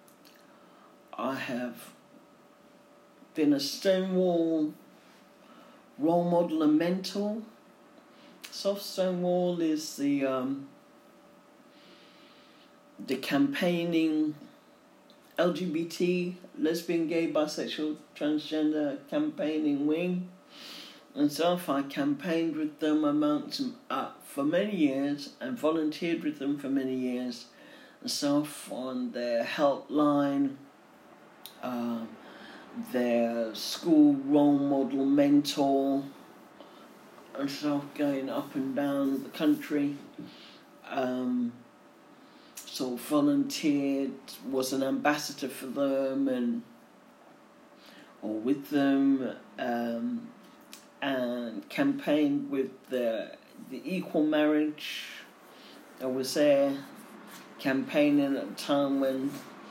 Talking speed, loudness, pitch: 90 wpm, -29 LUFS, 165 Hz